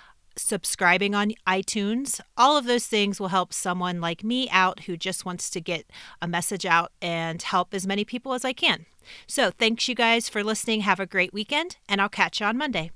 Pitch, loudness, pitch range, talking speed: 200 Hz, -24 LUFS, 180-230 Hz, 210 wpm